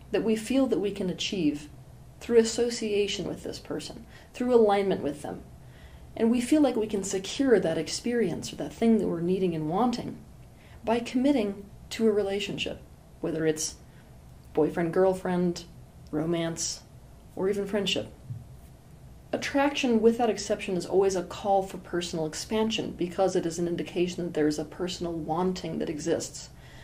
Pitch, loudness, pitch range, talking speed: 190 Hz, -28 LUFS, 165-220 Hz, 155 wpm